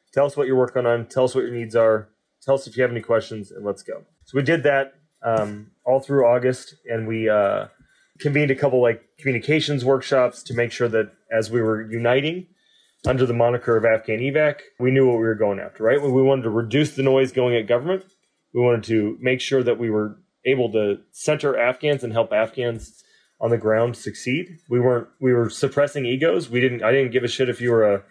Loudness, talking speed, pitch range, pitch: -21 LUFS, 230 wpm, 115-135 Hz, 125 Hz